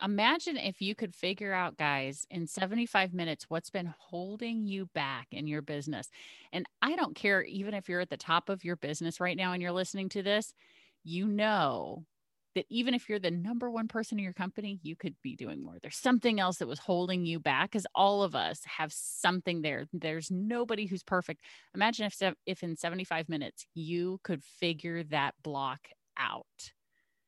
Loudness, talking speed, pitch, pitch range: -33 LUFS, 190 wpm, 180 Hz, 165-205 Hz